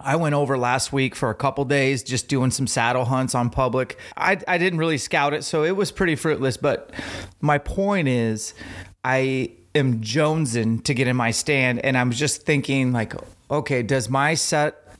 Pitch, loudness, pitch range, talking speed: 135 Hz, -22 LUFS, 125-150 Hz, 190 wpm